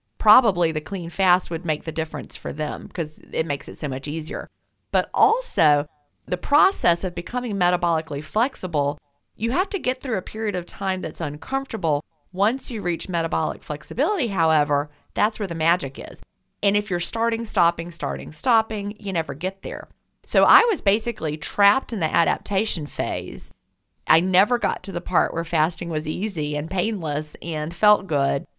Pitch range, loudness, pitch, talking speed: 155-215 Hz, -23 LUFS, 175 Hz, 170 wpm